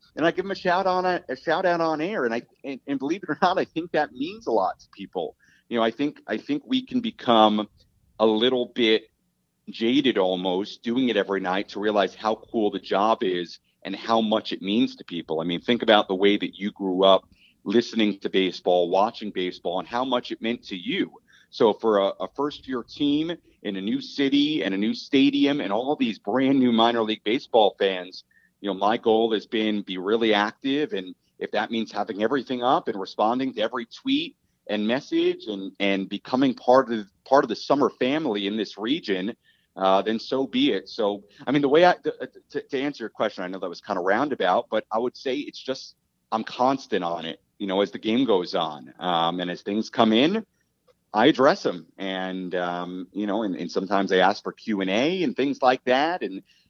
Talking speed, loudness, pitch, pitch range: 225 wpm, -24 LUFS, 115 Hz, 95-145 Hz